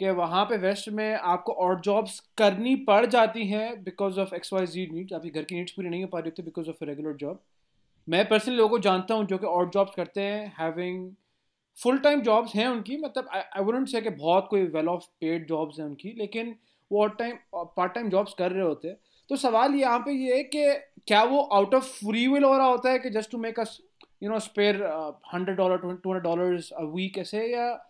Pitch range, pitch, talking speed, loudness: 180-230 Hz, 200 Hz, 230 wpm, -26 LUFS